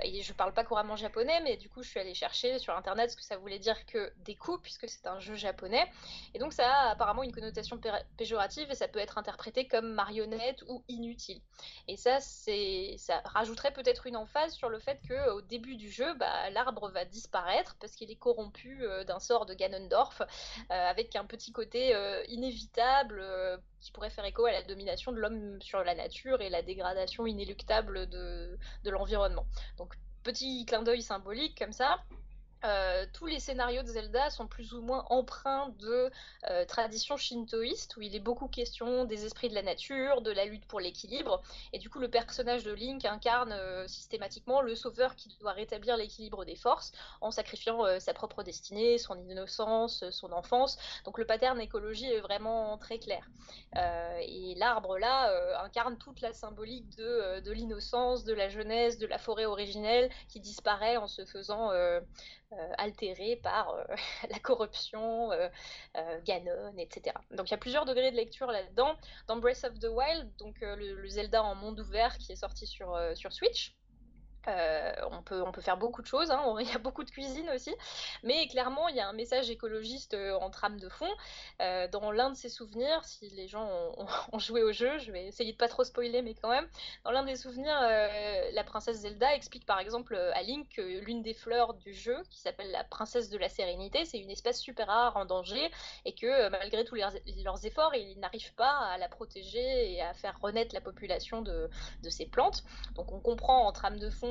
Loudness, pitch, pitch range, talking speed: -34 LUFS, 230 Hz, 205-255 Hz, 210 wpm